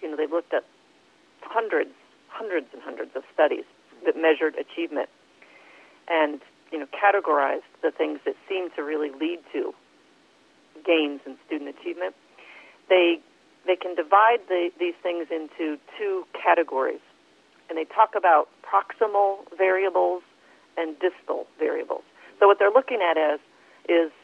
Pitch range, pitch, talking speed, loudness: 160-235 Hz, 180 Hz, 140 wpm, -24 LUFS